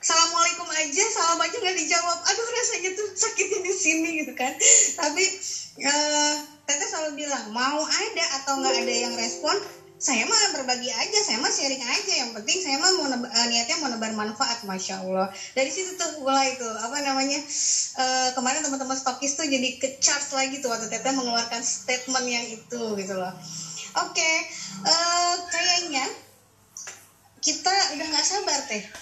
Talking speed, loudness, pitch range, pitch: 170 wpm, -23 LUFS, 255-345 Hz, 285 Hz